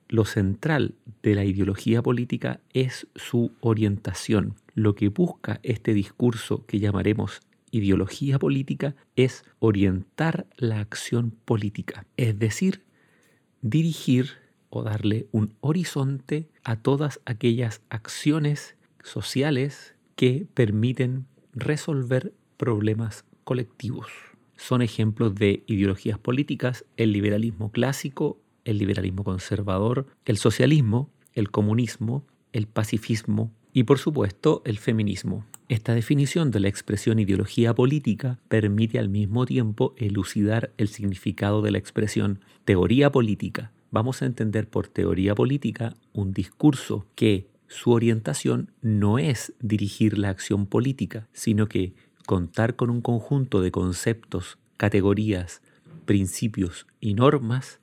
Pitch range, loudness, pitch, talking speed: 105-130 Hz, -25 LUFS, 115 Hz, 115 wpm